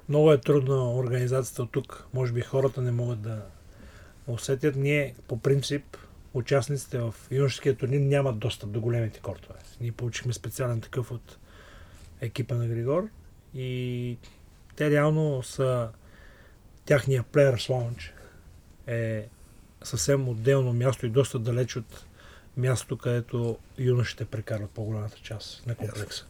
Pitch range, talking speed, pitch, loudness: 105-130 Hz, 130 wpm, 120 Hz, -28 LUFS